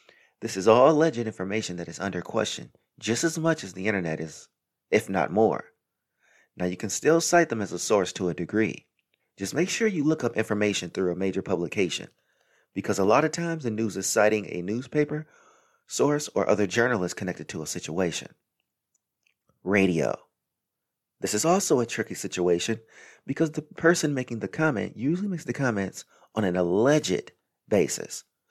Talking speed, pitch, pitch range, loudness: 175 wpm, 110 Hz, 95-155 Hz, -26 LUFS